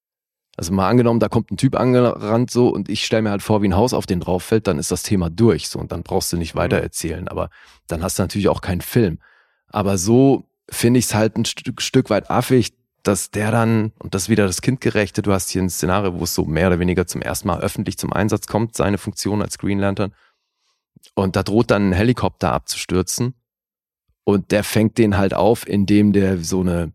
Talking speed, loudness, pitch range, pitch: 230 wpm, -19 LUFS, 95-115 Hz, 100 Hz